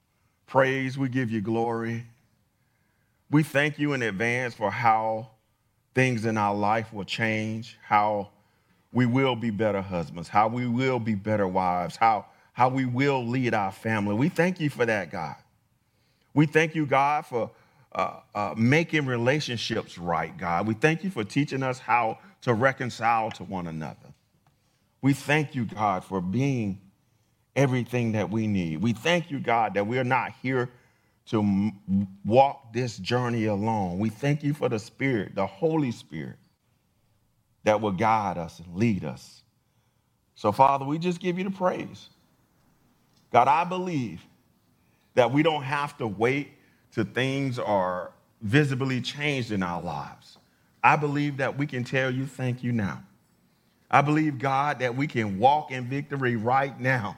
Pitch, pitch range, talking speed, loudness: 120 Hz, 110-135 Hz, 160 wpm, -26 LUFS